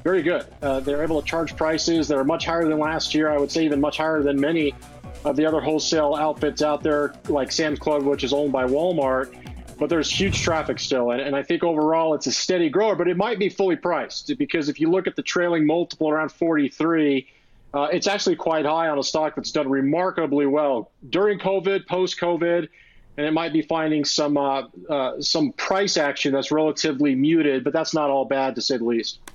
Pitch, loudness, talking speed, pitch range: 155 Hz, -22 LUFS, 220 wpm, 140-165 Hz